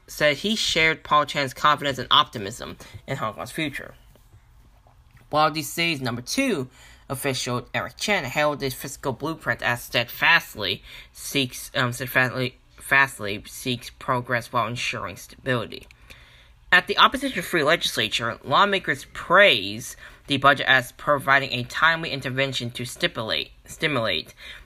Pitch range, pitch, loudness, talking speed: 125-150 Hz, 135 Hz, -22 LUFS, 125 wpm